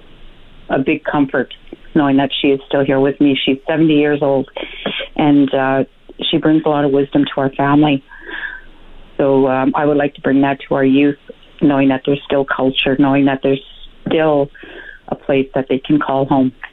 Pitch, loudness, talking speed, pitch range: 140 Hz, -15 LUFS, 190 wpm, 135-145 Hz